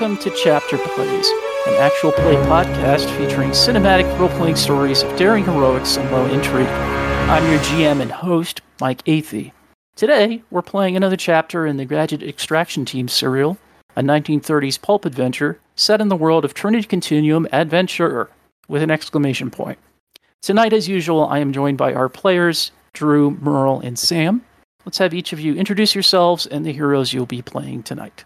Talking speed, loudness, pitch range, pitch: 170 wpm, -17 LUFS, 135-185 Hz, 155 Hz